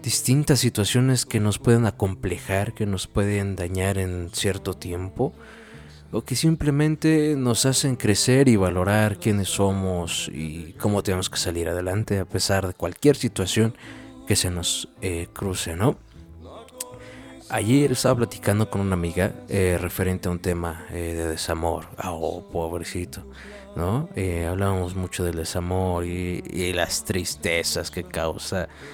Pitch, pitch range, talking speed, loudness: 95 Hz, 85-110 Hz, 140 wpm, -24 LUFS